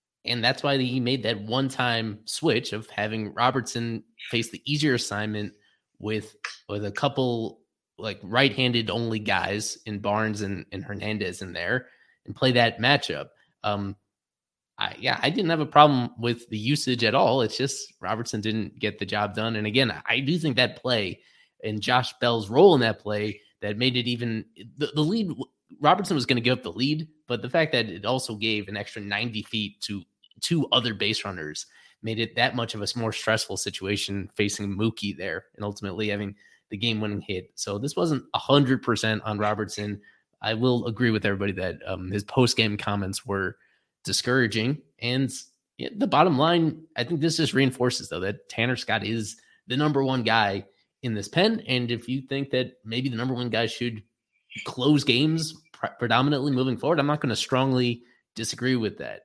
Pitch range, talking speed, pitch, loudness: 105-130 Hz, 190 wpm, 115 Hz, -25 LUFS